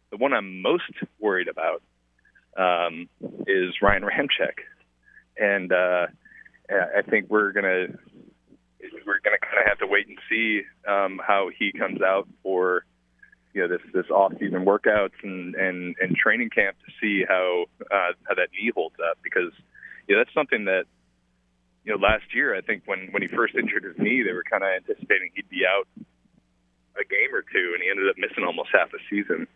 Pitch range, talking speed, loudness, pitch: 60-95 Hz, 185 wpm, -24 LUFS, 90 Hz